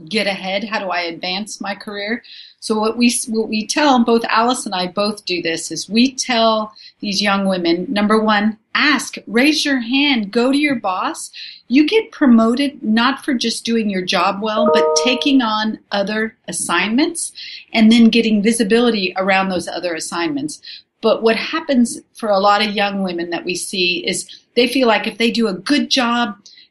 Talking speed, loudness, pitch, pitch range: 185 wpm, -16 LUFS, 220 Hz, 200-245 Hz